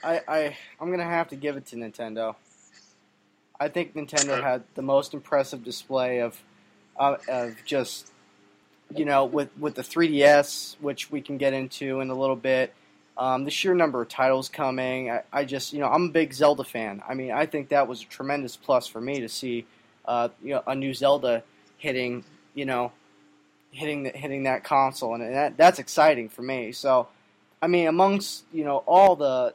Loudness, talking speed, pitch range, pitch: -25 LUFS, 190 wpm, 120-145 Hz, 135 Hz